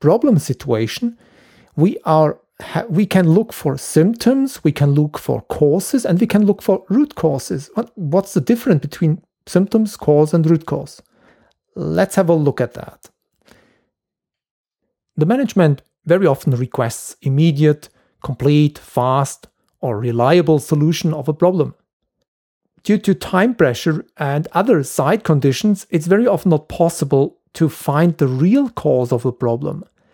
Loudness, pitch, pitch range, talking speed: -17 LUFS, 160 Hz, 145-195 Hz, 140 wpm